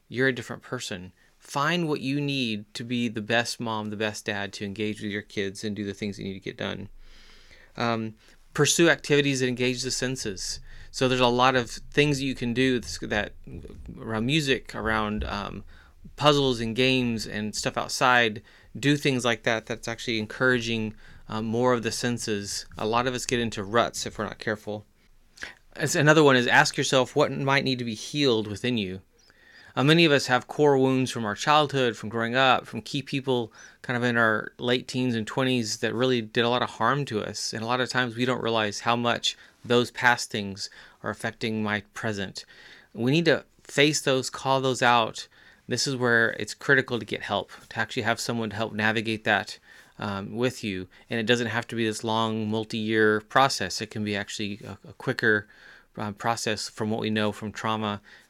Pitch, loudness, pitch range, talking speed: 115 Hz, -25 LUFS, 110-130 Hz, 205 wpm